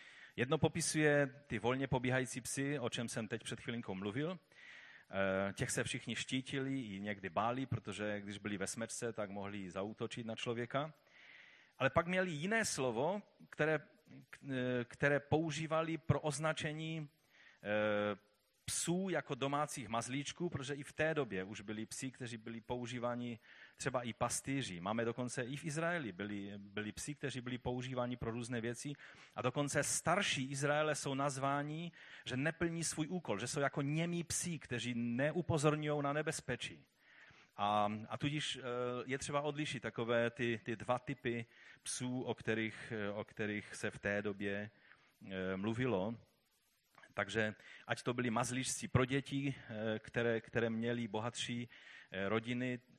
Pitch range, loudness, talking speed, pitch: 115-145 Hz, -39 LUFS, 140 wpm, 125 Hz